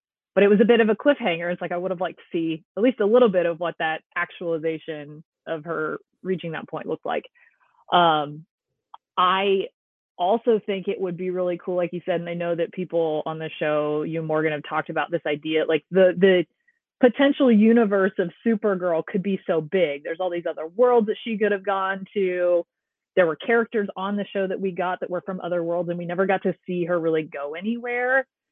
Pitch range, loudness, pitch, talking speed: 165-205 Hz, -23 LUFS, 180 Hz, 225 wpm